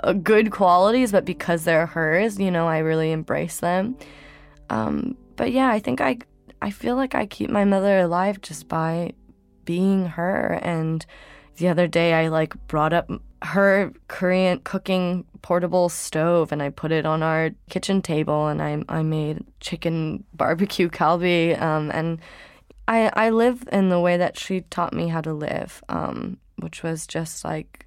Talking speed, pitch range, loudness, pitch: 170 wpm, 160-195 Hz, -22 LUFS, 175 Hz